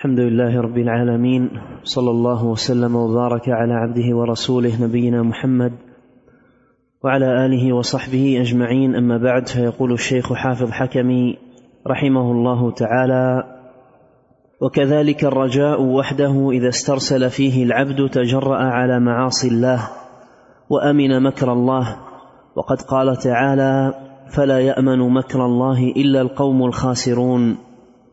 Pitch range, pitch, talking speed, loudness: 125-130 Hz, 125 Hz, 105 wpm, -17 LUFS